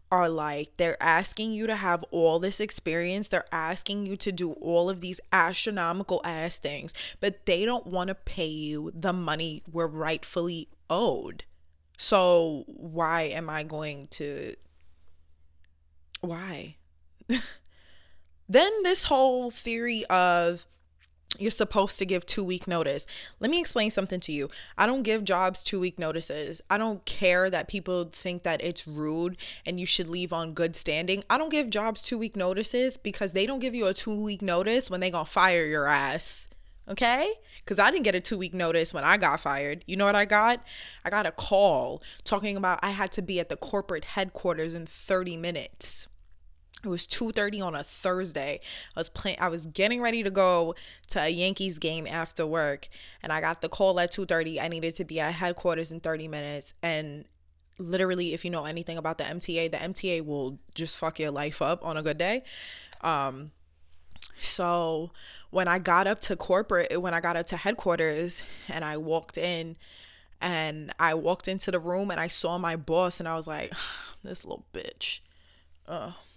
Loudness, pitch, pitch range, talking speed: -28 LUFS, 175 Hz, 155-190 Hz, 185 wpm